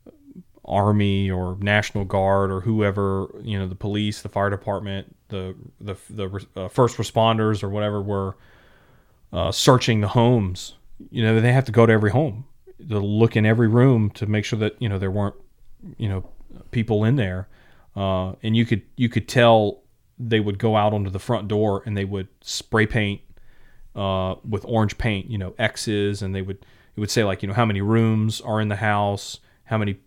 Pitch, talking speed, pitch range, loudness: 105 Hz, 195 wpm, 100-115 Hz, -22 LUFS